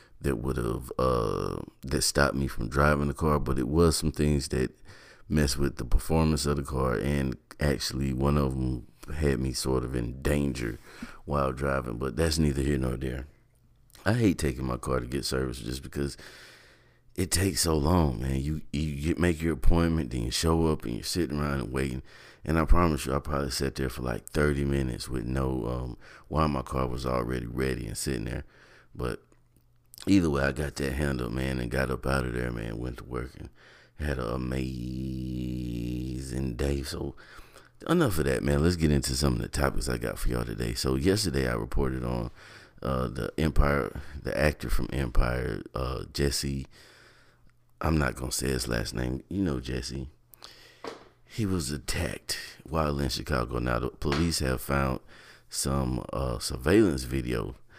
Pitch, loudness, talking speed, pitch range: 70 Hz, -29 LUFS, 185 wpm, 65-75 Hz